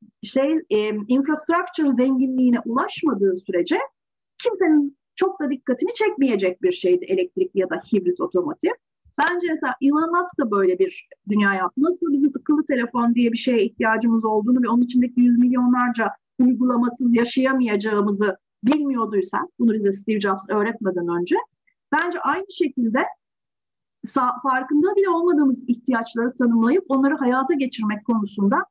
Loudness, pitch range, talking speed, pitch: -21 LUFS, 225-320 Hz, 125 wpm, 255 Hz